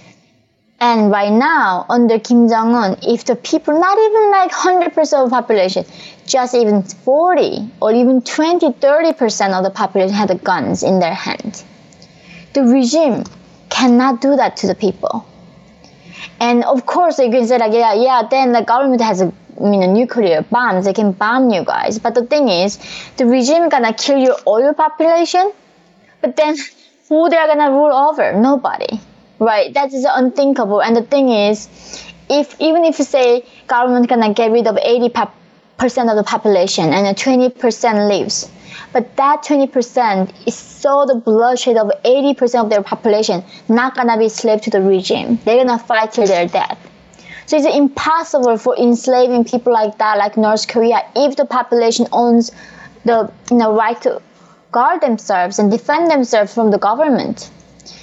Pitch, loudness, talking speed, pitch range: 235 Hz, -14 LUFS, 170 wpm, 210-275 Hz